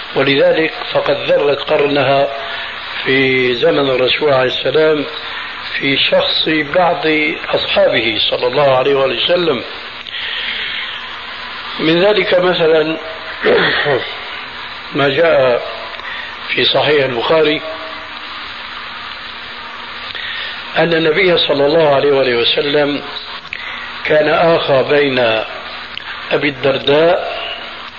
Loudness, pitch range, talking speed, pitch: -14 LUFS, 140-165 Hz, 75 wpm, 155 Hz